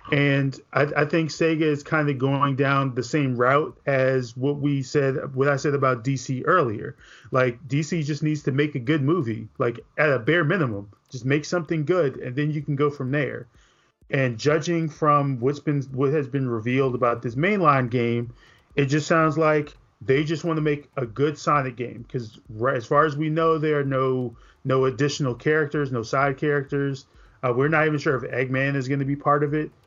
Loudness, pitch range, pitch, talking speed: -23 LUFS, 130-150 Hz, 140 Hz, 210 wpm